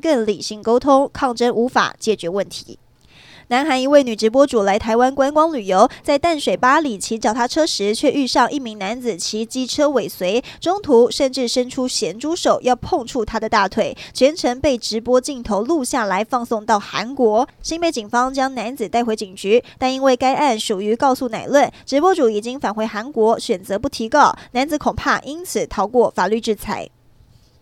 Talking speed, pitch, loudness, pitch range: 280 characters per minute, 245 Hz, -18 LUFS, 220-275 Hz